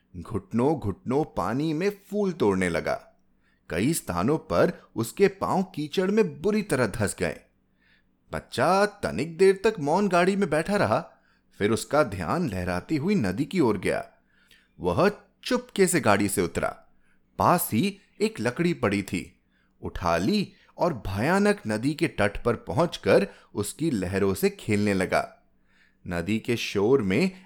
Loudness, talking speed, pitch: -26 LUFS, 145 wpm, 155 Hz